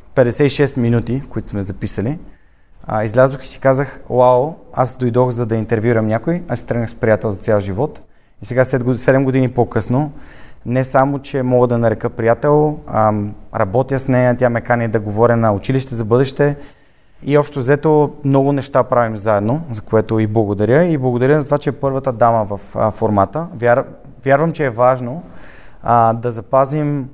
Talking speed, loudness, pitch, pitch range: 165 wpm, -16 LUFS, 125 Hz, 115-135 Hz